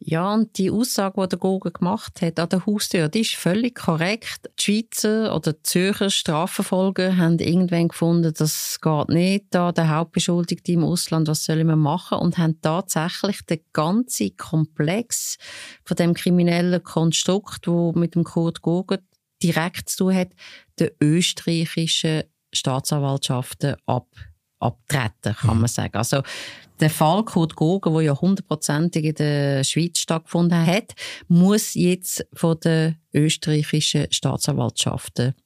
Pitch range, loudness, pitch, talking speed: 155-185 Hz, -21 LUFS, 165 Hz, 140 wpm